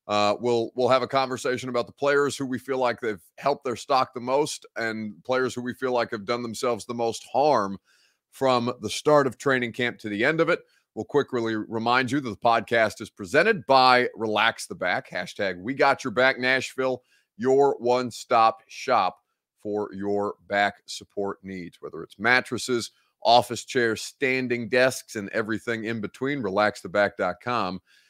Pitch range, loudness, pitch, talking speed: 105-130 Hz, -25 LUFS, 120 Hz, 175 wpm